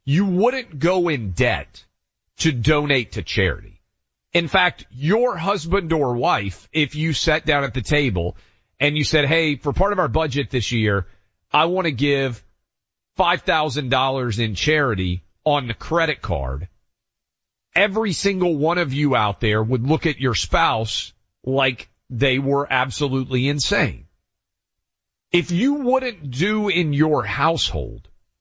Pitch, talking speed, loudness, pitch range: 135 Hz, 145 wpm, -20 LUFS, 100-160 Hz